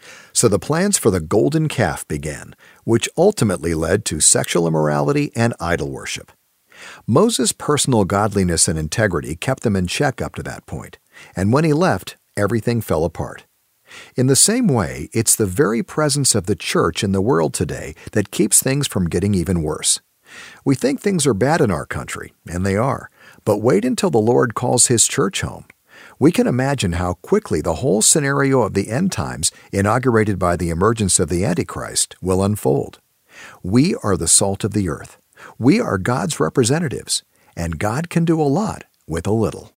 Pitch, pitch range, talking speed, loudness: 110 Hz, 95-140 Hz, 180 wpm, -18 LUFS